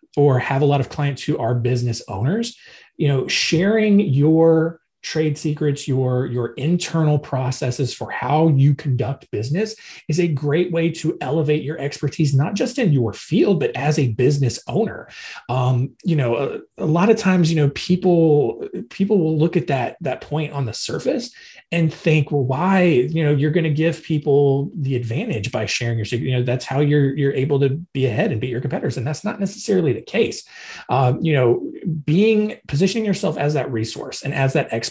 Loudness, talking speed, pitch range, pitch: -20 LUFS, 195 wpm, 130-165 Hz, 145 Hz